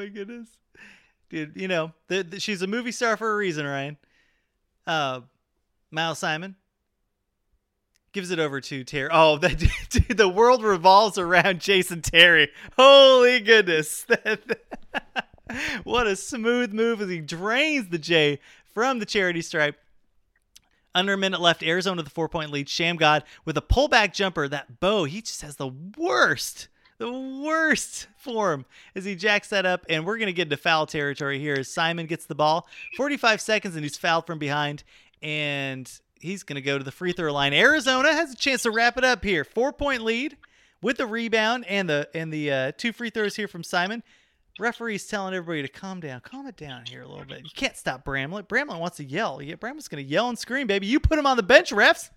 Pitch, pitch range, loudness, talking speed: 185 Hz, 150-225 Hz, -22 LUFS, 195 wpm